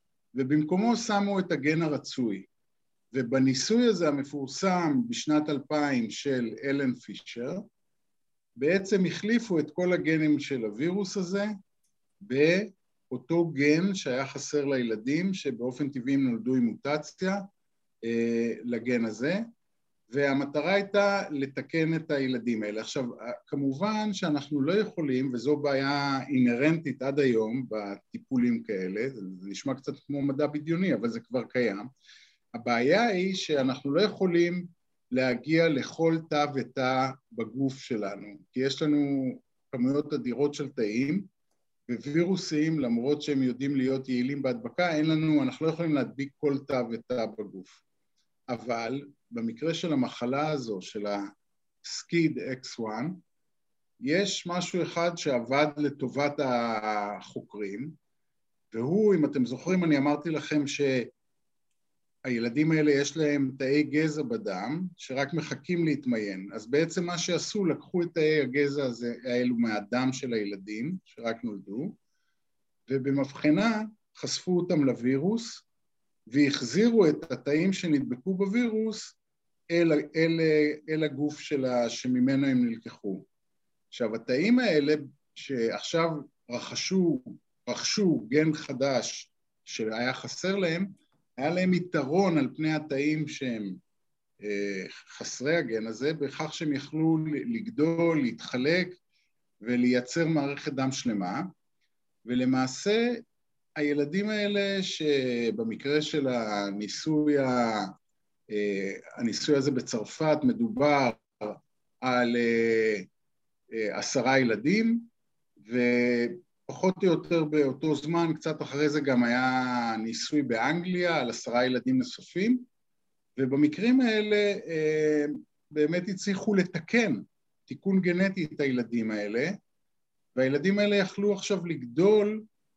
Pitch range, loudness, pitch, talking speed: 130-175 Hz, -28 LUFS, 145 Hz, 105 wpm